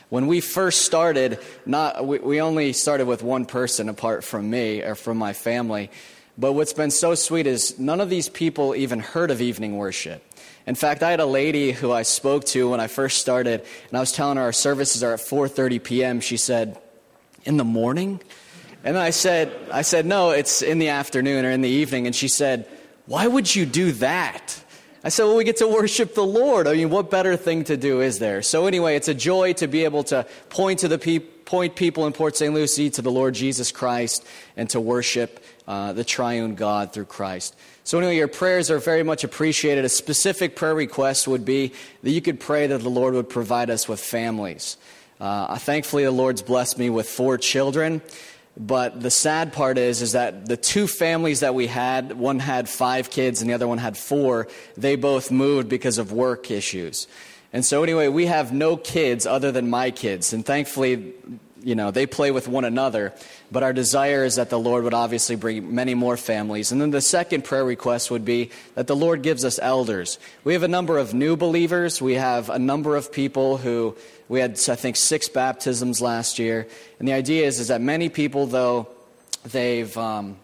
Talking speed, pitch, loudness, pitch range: 210 wpm, 130 Hz, -22 LUFS, 120-155 Hz